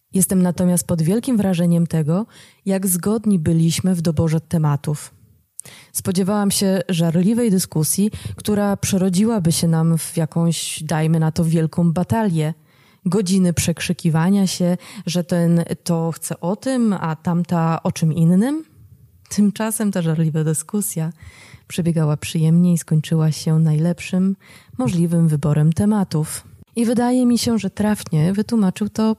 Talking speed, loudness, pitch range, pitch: 125 wpm, -19 LUFS, 160-195 Hz, 175 Hz